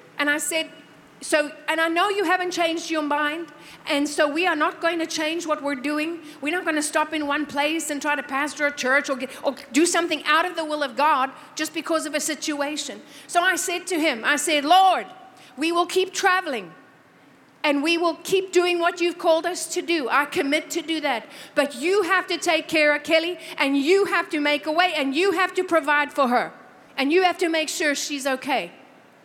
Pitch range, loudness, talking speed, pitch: 295-345 Hz, -22 LUFS, 230 wpm, 315 Hz